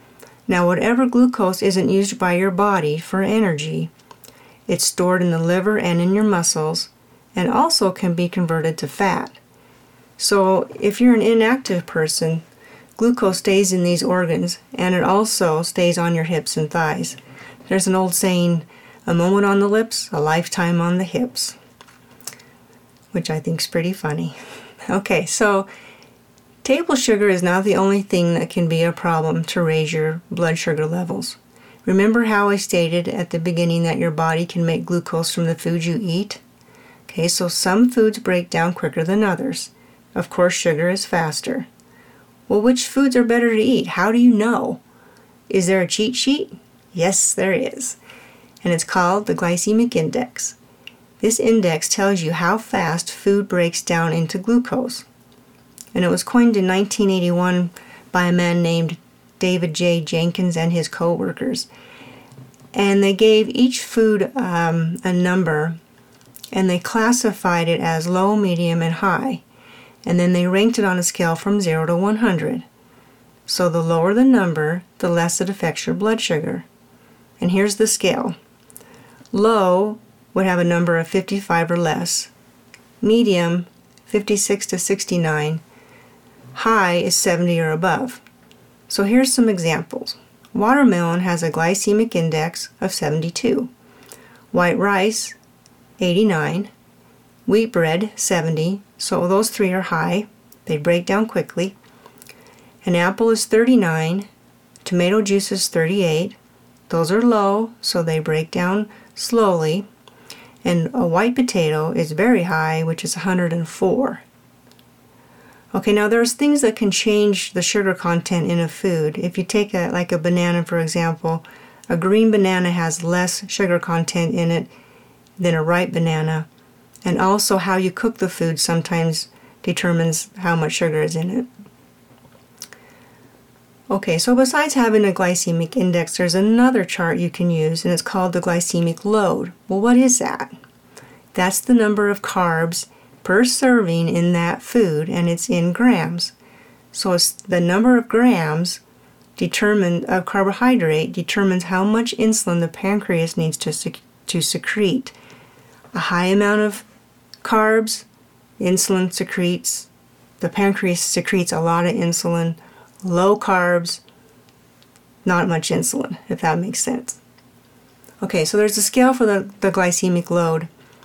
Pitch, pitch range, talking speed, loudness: 180 Hz, 170-210 Hz, 150 wpm, -18 LUFS